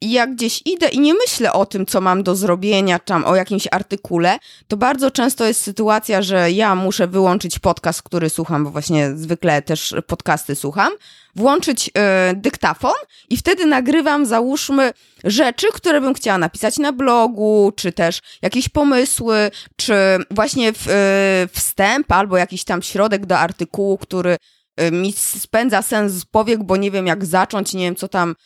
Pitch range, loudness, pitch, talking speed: 180-235 Hz, -17 LUFS, 200 Hz, 170 wpm